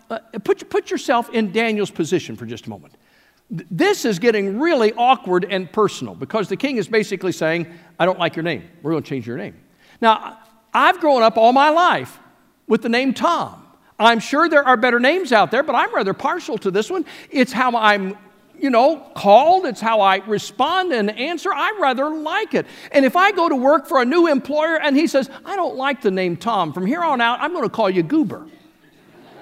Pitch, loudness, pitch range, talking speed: 235 Hz, -18 LUFS, 200-300 Hz, 215 wpm